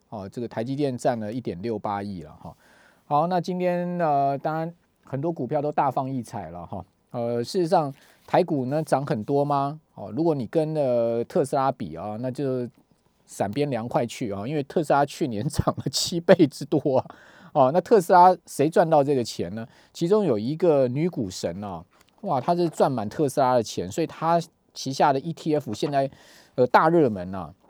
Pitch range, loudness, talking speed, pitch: 115-160 Hz, -24 LUFS, 280 characters per minute, 140 Hz